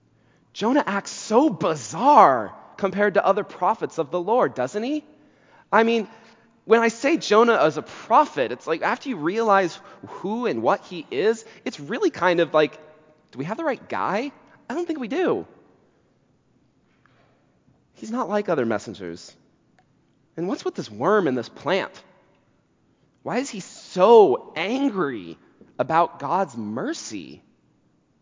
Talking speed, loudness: 145 wpm, -22 LUFS